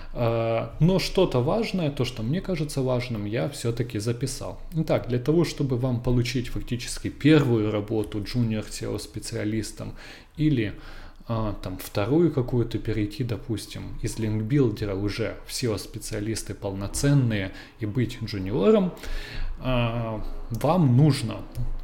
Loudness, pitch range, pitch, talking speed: -26 LUFS, 105-135 Hz, 115 Hz, 110 wpm